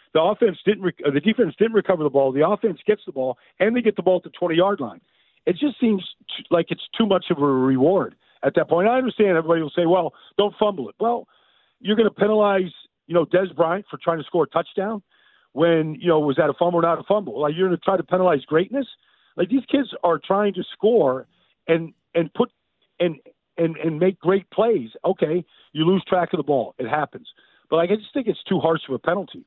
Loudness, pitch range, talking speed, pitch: -21 LUFS, 165-205 Hz, 240 wpm, 180 Hz